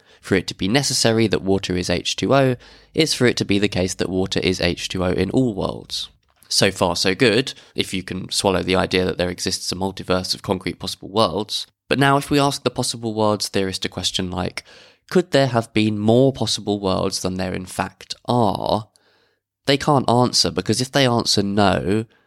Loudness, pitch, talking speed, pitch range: -20 LUFS, 100 Hz, 200 wpm, 95-120 Hz